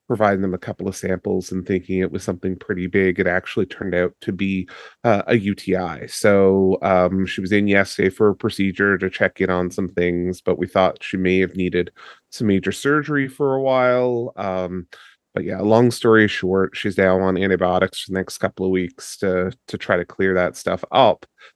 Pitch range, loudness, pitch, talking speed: 90-100 Hz, -20 LUFS, 95 Hz, 205 wpm